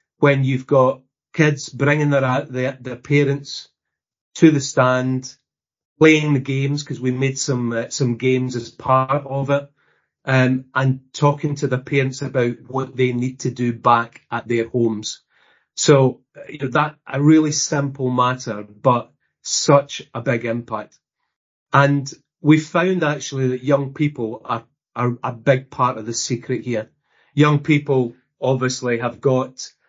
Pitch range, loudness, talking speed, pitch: 125-145 Hz, -19 LUFS, 155 wpm, 130 Hz